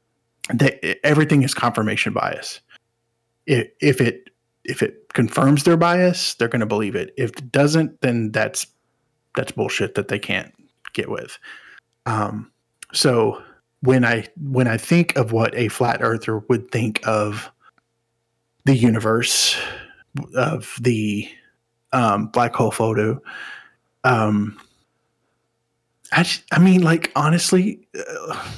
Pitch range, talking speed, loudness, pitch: 115-155 Hz, 130 wpm, -19 LUFS, 120 Hz